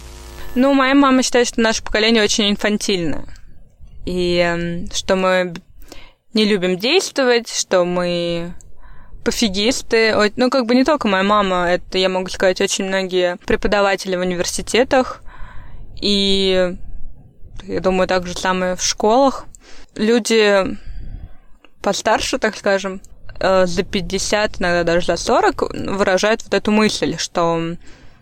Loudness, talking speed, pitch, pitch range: -17 LUFS, 120 wpm, 195 Hz, 180-220 Hz